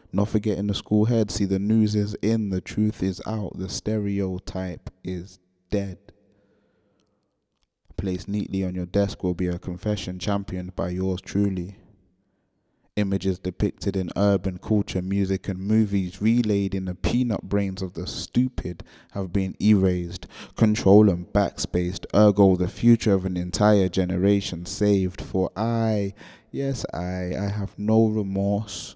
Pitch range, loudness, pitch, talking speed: 95-105 Hz, -24 LUFS, 100 Hz, 145 wpm